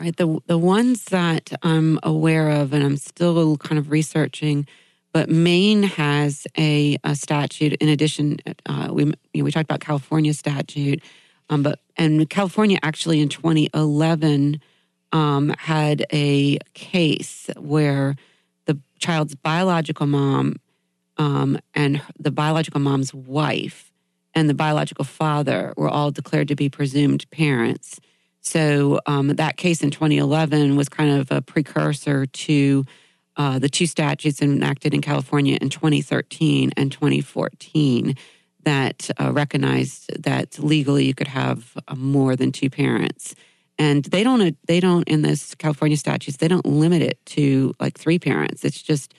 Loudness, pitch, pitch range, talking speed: -20 LUFS, 150 Hz, 140-155 Hz, 145 wpm